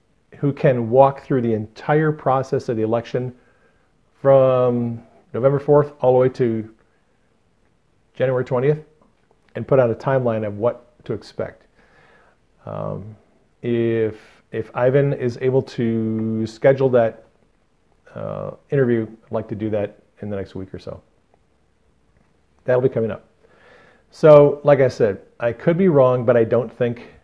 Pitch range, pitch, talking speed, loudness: 110-135 Hz, 120 Hz, 145 wpm, -19 LUFS